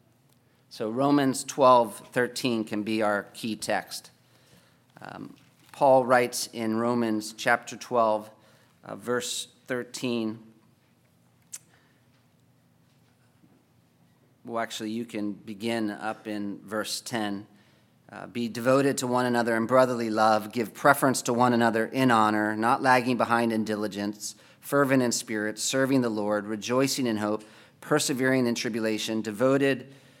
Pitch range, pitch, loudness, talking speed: 110-125 Hz, 115 Hz, -26 LUFS, 125 wpm